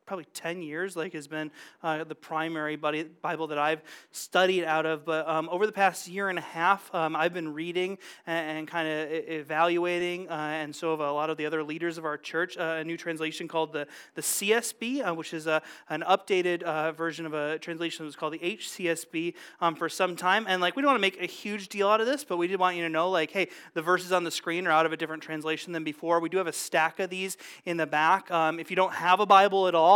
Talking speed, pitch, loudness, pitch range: 260 wpm, 165 Hz, -28 LUFS, 155-180 Hz